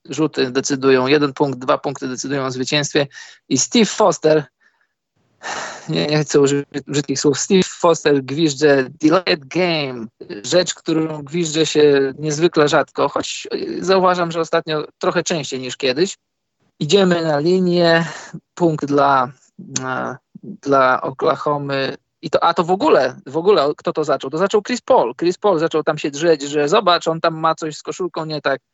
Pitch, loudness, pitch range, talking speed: 155 Hz, -17 LUFS, 140-175 Hz, 160 wpm